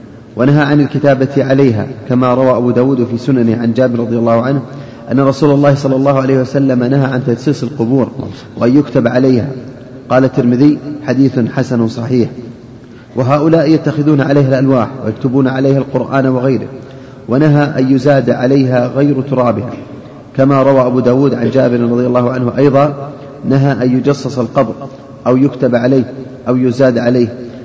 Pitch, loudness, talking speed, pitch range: 130 Hz, -12 LUFS, 150 wpm, 125-140 Hz